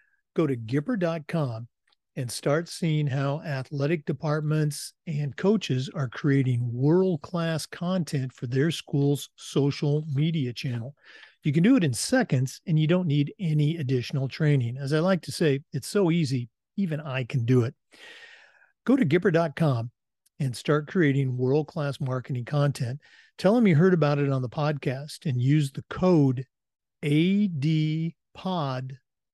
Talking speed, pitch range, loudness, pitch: 145 wpm, 135-165 Hz, -26 LUFS, 150 Hz